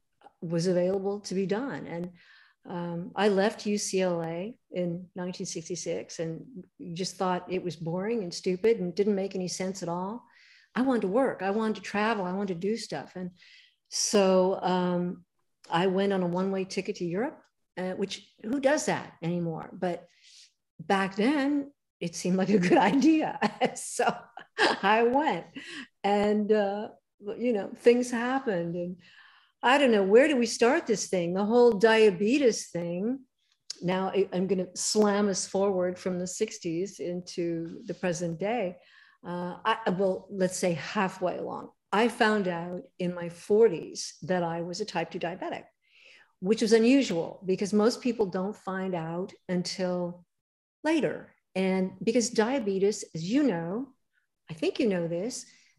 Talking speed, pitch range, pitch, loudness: 155 wpm, 180-225 Hz, 195 Hz, -28 LUFS